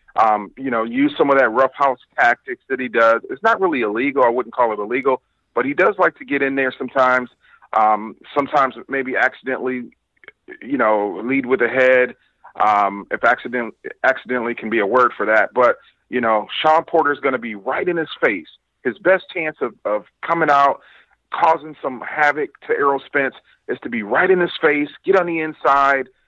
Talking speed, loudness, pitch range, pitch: 200 wpm, -18 LUFS, 125-160 Hz, 135 Hz